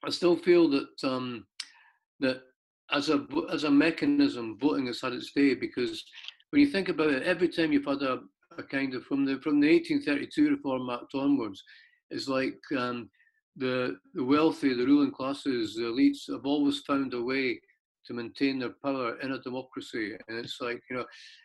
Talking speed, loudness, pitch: 185 wpm, -29 LUFS, 150 Hz